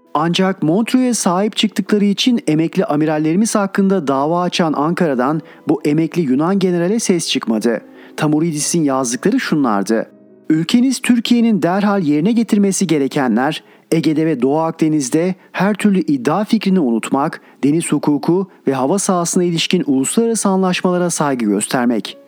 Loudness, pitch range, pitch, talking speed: -16 LUFS, 150-200 Hz, 170 Hz, 120 wpm